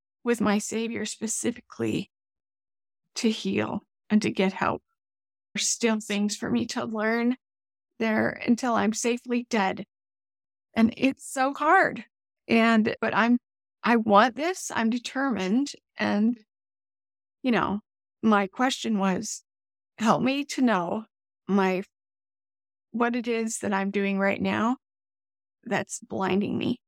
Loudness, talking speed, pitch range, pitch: -26 LUFS, 125 wpm, 195-240 Hz, 220 Hz